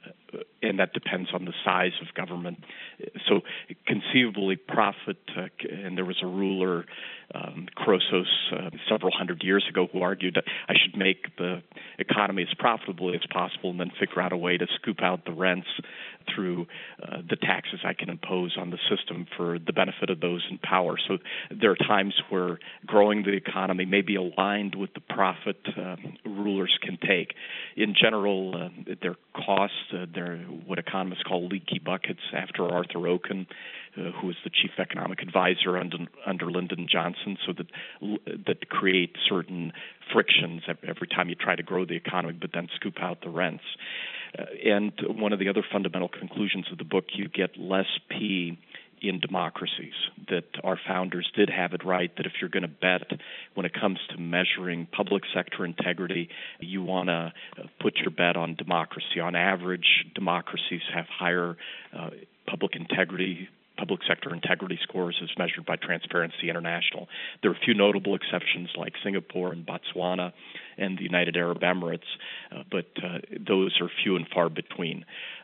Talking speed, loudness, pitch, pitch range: 170 wpm, -28 LUFS, 90 Hz, 90-95 Hz